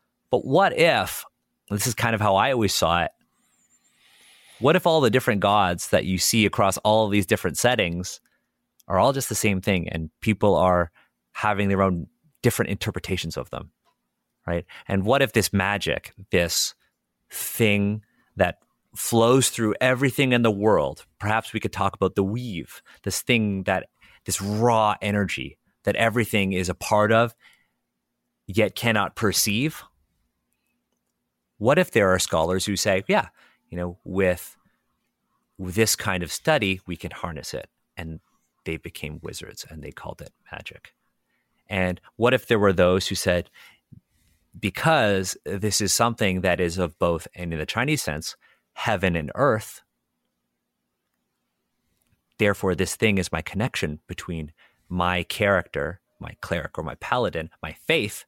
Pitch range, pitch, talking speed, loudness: 85-110 Hz, 95 Hz, 155 wpm, -23 LUFS